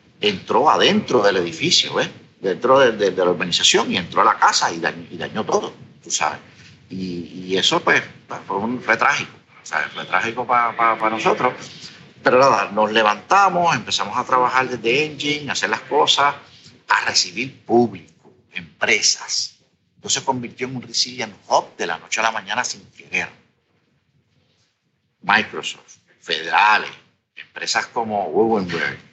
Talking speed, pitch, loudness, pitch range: 155 wpm, 120 Hz, -18 LUFS, 110-130 Hz